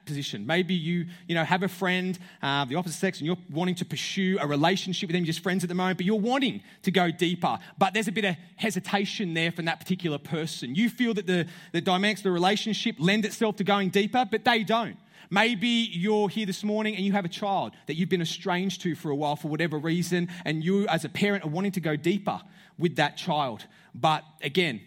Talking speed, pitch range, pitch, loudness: 230 wpm, 170-200 Hz, 185 Hz, -27 LUFS